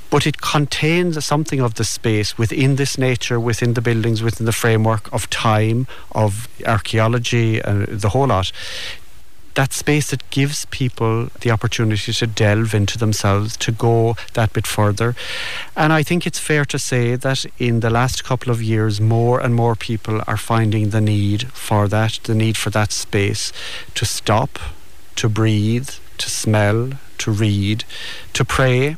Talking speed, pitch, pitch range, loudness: 165 wpm, 115 Hz, 110-125 Hz, -18 LUFS